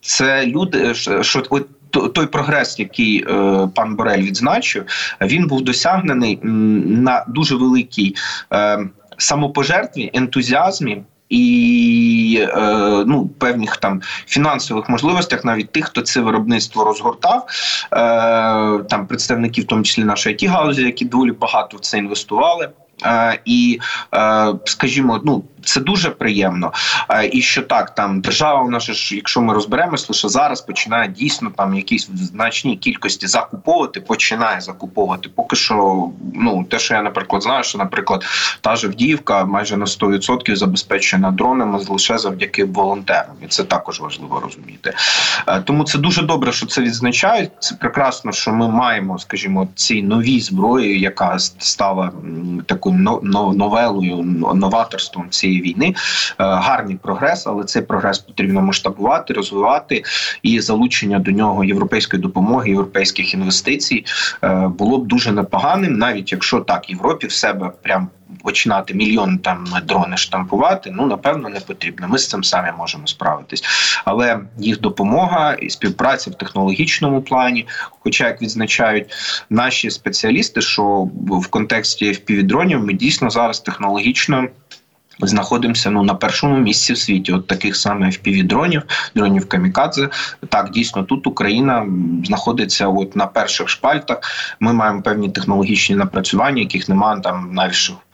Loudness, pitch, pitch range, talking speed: -16 LUFS, 110 Hz, 100-130 Hz, 130 wpm